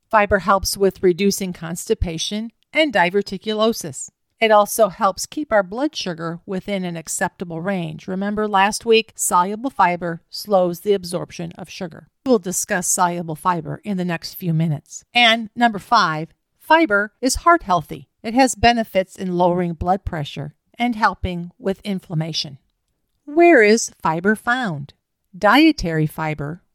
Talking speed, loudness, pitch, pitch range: 135 wpm, -19 LUFS, 195 Hz, 170-220 Hz